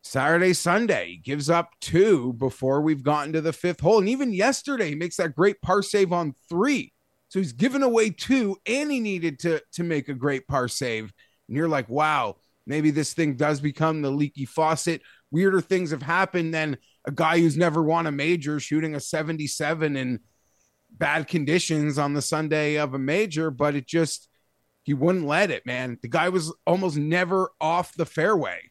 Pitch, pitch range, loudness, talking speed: 160 Hz, 145-180 Hz, -24 LUFS, 190 wpm